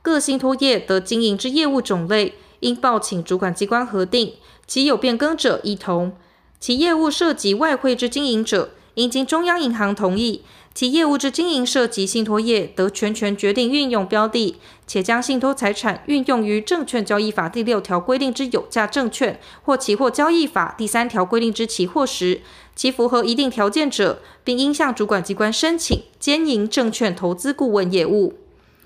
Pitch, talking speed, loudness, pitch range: 235 Hz, 275 characters per minute, -19 LUFS, 205-275 Hz